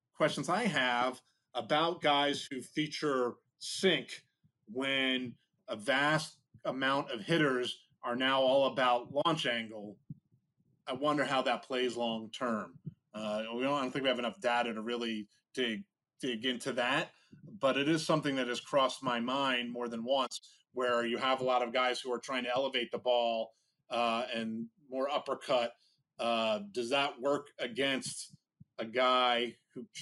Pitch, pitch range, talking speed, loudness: 125 Hz, 120-140 Hz, 160 wpm, -33 LUFS